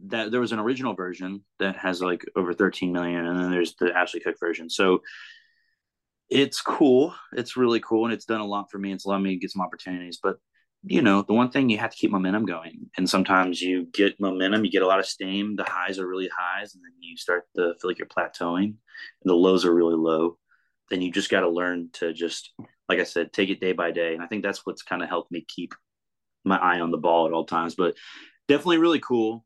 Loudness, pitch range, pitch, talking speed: -25 LUFS, 90-110 Hz, 95 Hz, 245 wpm